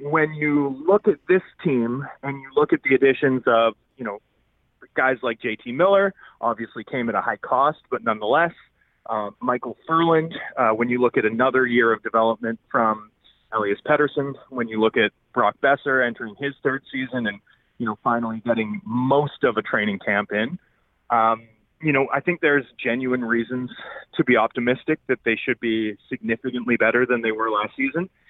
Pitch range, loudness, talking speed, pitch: 115-140 Hz, -22 LUFS, 180 wpm, 125 Hz